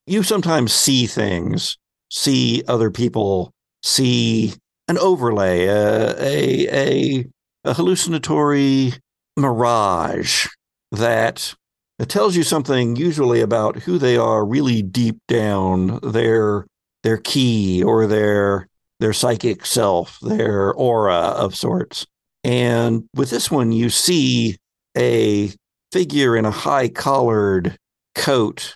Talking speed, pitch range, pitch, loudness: 115 wpm, 105-135 Hz, 115 Hz, -18 LUFS